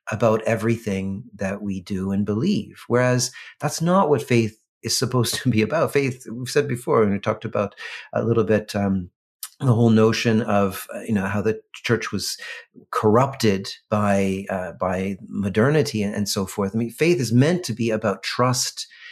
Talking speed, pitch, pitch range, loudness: 175 wpm, 110 Hz, 100-125 Hz, -22 LUFS